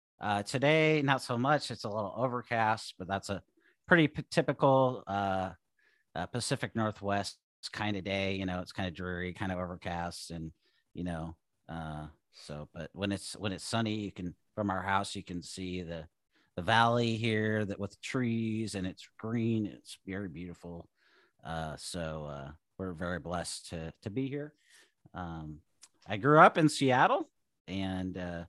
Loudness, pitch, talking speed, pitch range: -32 LUFS, 95 Hz, 170 wpm, 85-115 Hz